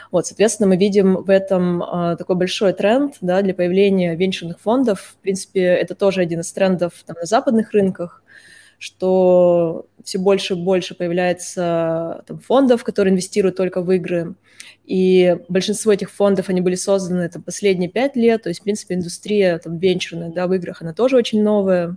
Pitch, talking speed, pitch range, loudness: 185 Hz, 175 wpm, 175-200 Hz, -18 LUFS